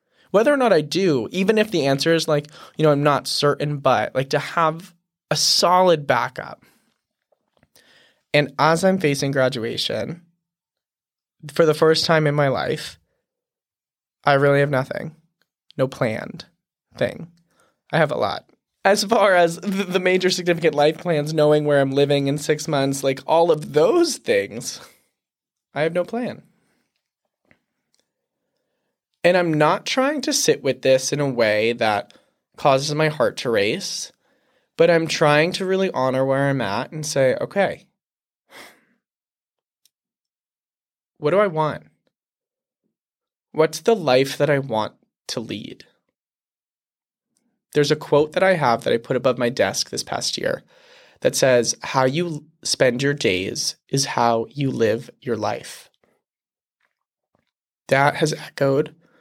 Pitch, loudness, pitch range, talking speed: 155 Hz, -20 LUFS, 140-175 Hz, 145 wpm